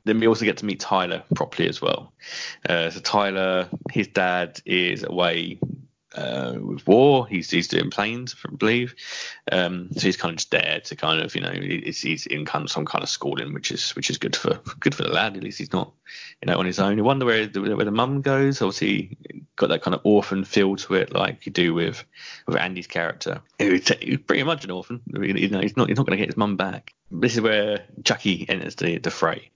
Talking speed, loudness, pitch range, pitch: 235 wpm, -23 LUFS, 90-115 Hz, 100 Hz